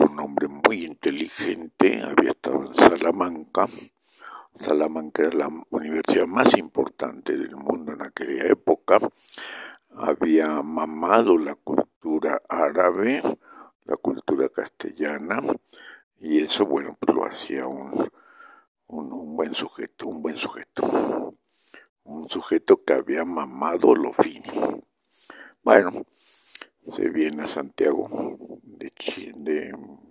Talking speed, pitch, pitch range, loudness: 100 wpm, 345 Hz, 270-410 Hz, -24 LUFS